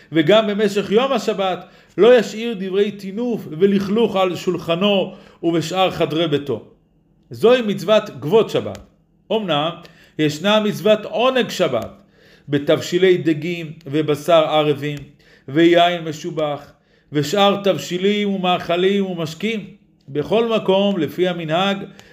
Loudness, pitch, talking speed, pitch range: -18 LUFS, 180 Hz, 100 wpm, 160-205 Hz